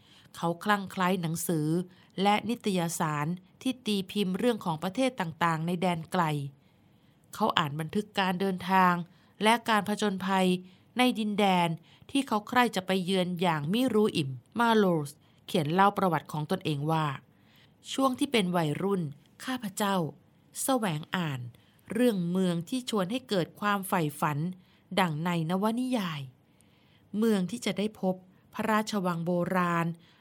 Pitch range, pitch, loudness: 170-210 Hz, 185 Hz, -29 LUFS